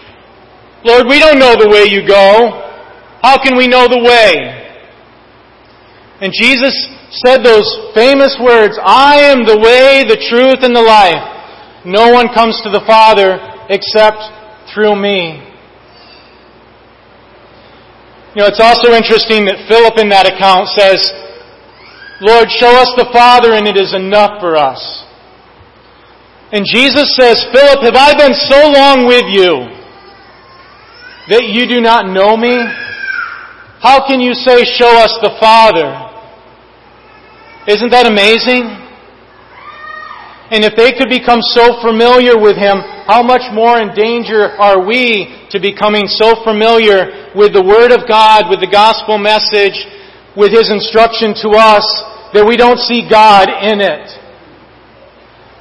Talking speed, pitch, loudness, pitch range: 140 wpm, 230 Hz, -7 LUFS, 210-255 Hz